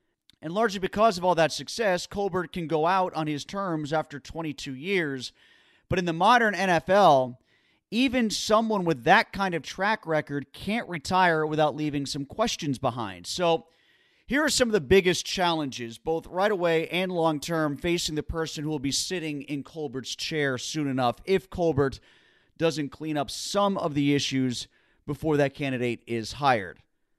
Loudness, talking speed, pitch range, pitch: -26 LUFS, 170 wpm, 140-185 Hz, 160 Hz